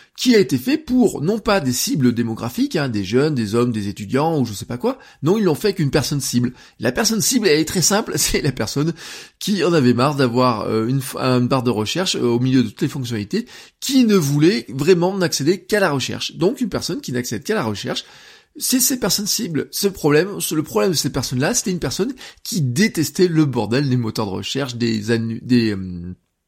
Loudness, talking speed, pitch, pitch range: -19 LUFS, 230 wpm, 145 Hz, 120-195 Hz